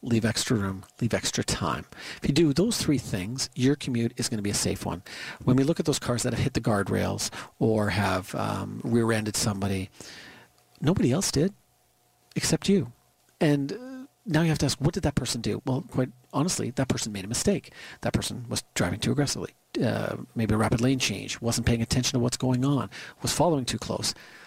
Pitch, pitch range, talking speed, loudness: 120 Hz, 105-135 Hz, 205 wpm, -27 LUFS